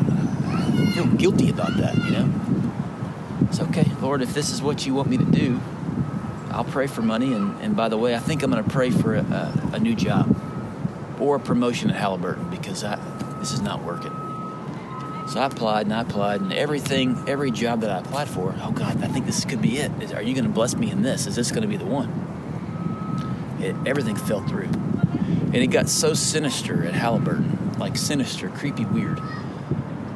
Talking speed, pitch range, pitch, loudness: 205 wpm, 125-185 Hz, 135 Hz, -24 LUFS